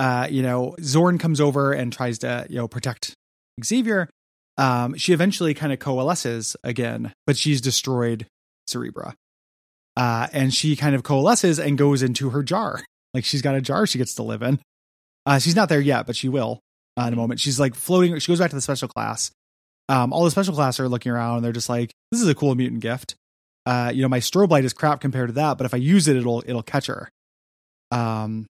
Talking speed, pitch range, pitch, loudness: 225 wpm, 120-145 Hz, 130 Hz, -22 LUFS